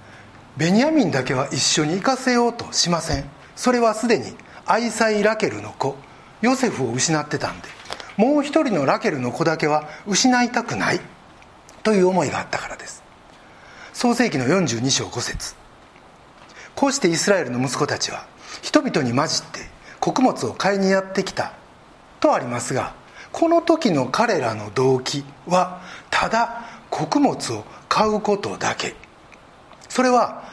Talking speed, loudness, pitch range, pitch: 285 characters per minute, -21 LUFS, 140-235 Hz, 195 Hz